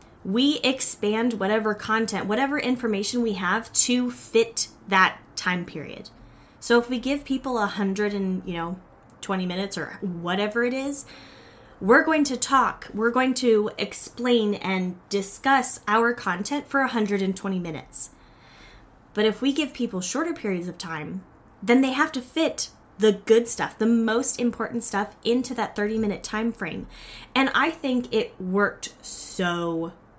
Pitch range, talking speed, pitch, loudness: 195-255 Hz, 150 wpm, 220 Hz, -24 LUFS